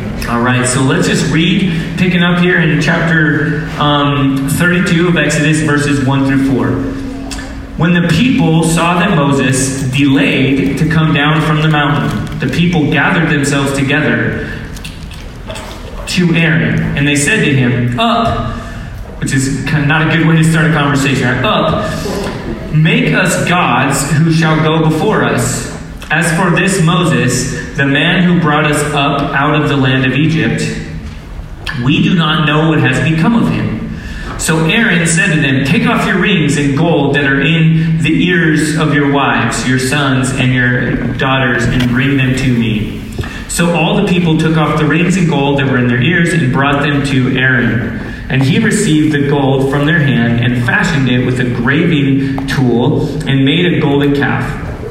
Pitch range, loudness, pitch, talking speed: 130-160 Hz, -11 LUFS, 145 Hz, 175 wpm